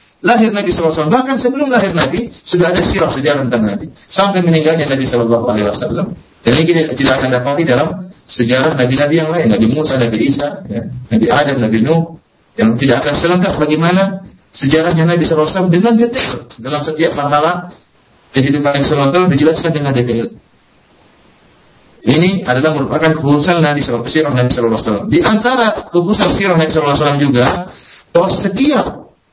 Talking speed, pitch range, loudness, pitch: 155 wpm, 130-180 Hz, -12 LUFS, 155 Hz